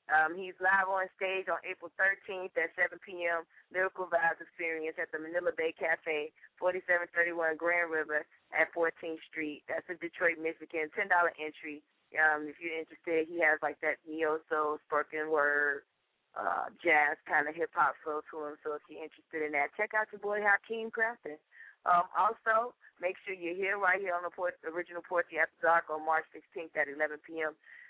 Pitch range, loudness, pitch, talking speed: 155-185 Hz, -32 LUFS, 165 Hz, 185 wpm